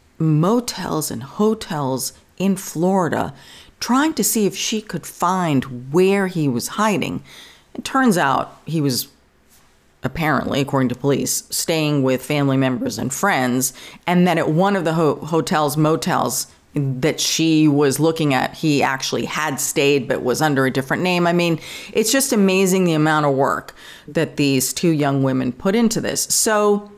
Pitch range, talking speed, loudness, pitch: 135-190 Hz, 160 wpm, -19 LUFS, 155 Hz